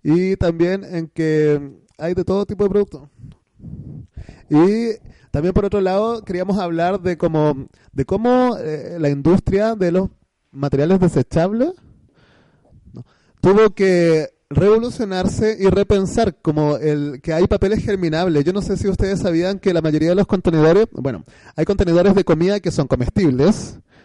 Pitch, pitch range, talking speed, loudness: 180 Hz, 155-200 Hz, 145 wpm, -18 LUFS